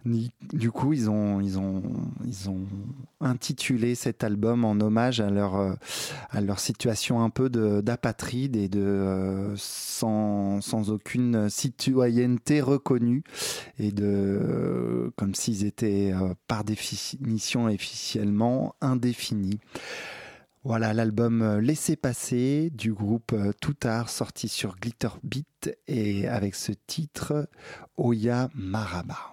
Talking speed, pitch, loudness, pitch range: 115 wpm, 115 Hz, -27 LUFS, 100-125 Hz